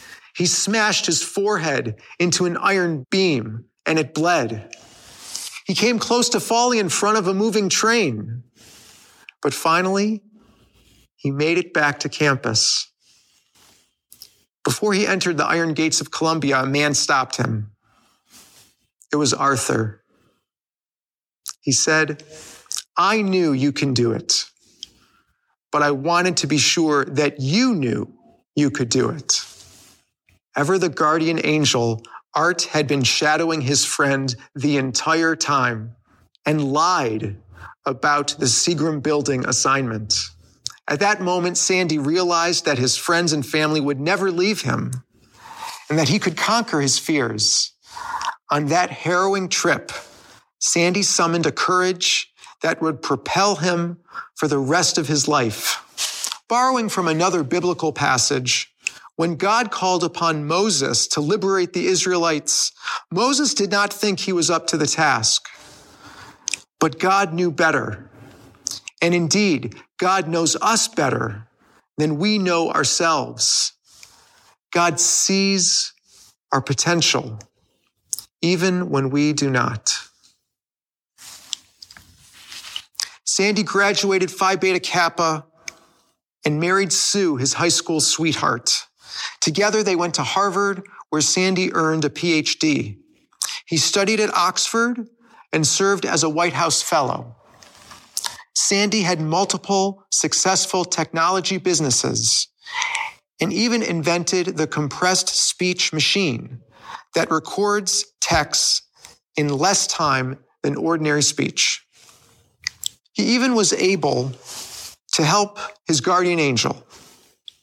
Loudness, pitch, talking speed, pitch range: -19 LUFS, 165 Hz, 120 wpm, 140-190 Hz